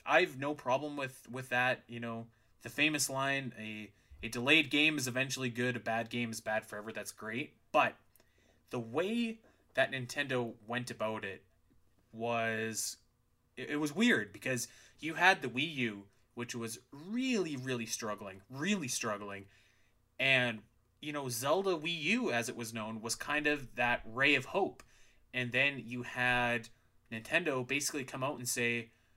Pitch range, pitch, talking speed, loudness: 115-140 Hz, 120 Hz, 160 wpm, -34 LUFS